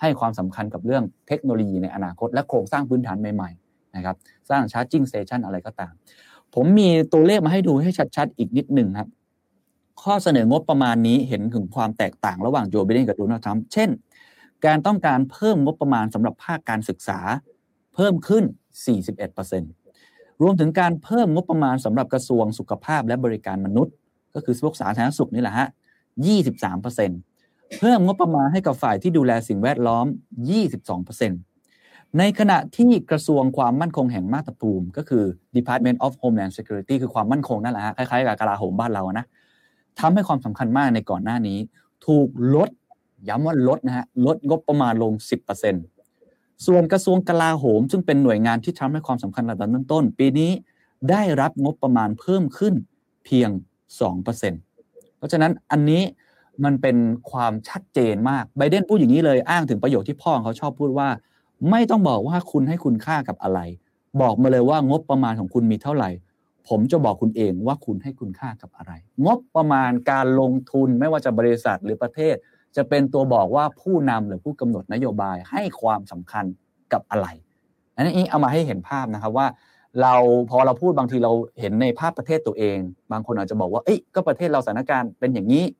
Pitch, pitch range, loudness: 130 Hz, 110-155 Hz, -21 LUFS